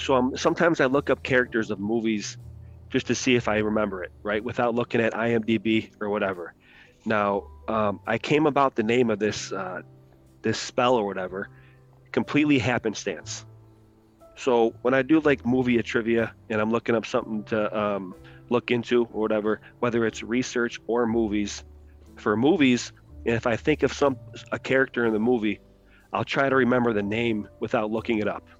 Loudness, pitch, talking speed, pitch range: -25 LUFS, 115 Hz, 175 wpm, 105-125 Hz